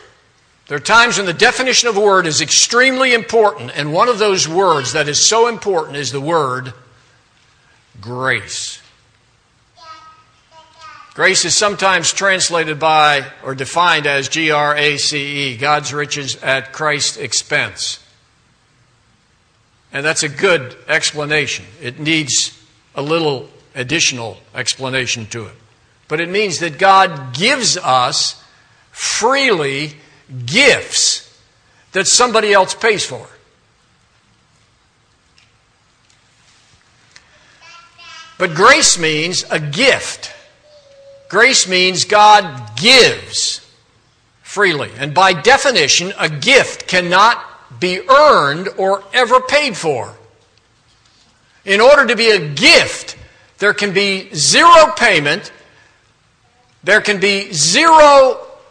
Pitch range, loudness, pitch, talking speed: 130-210 Hz, -12 LUFS, 160 Hz, 110 wpm